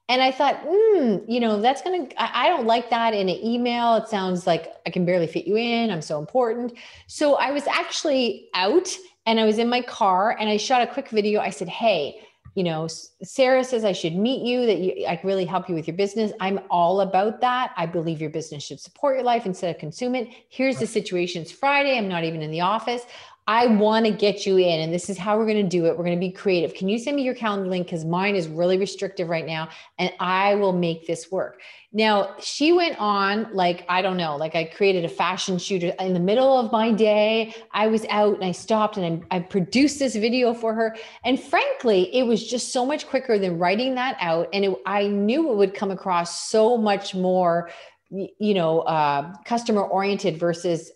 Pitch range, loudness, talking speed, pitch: 180-235 Hz, -22 LUFS, 230 wpm, 205 Hz